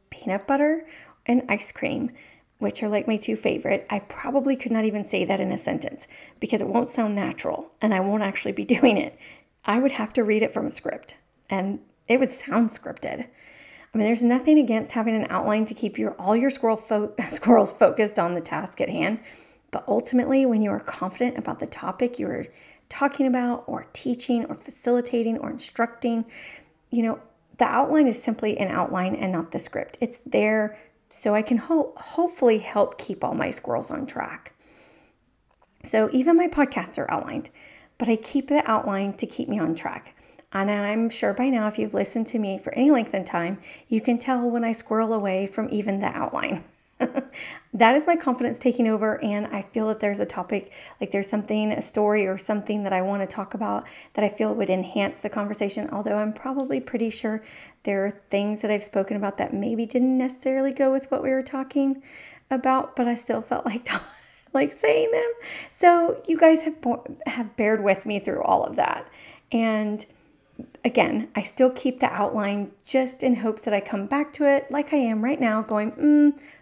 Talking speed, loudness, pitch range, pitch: 200 wpm, -24 LUFS, 210-265 Hz, 230 Hz